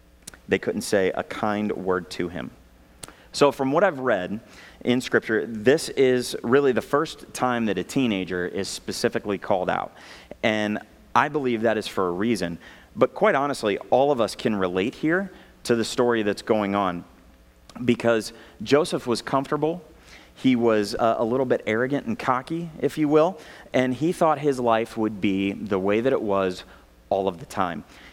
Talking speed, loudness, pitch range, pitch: 175 wpm, -24 LUFS, 95-135 Hz, 115 Hz